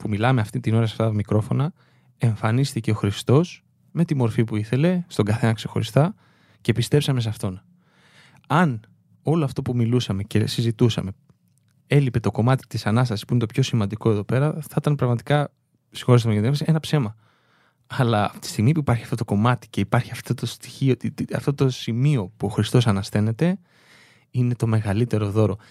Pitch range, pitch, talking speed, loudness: 110-140 Hz, 120 Hz, 180 wpm, -22 LUFS